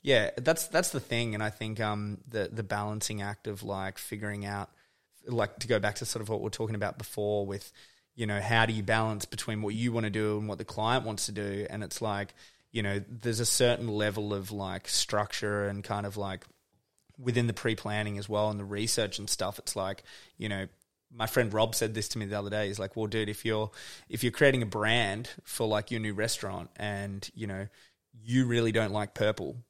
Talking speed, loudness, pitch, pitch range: 230 wpm, -31 LUFS, 105 Hz, 100-115 Hz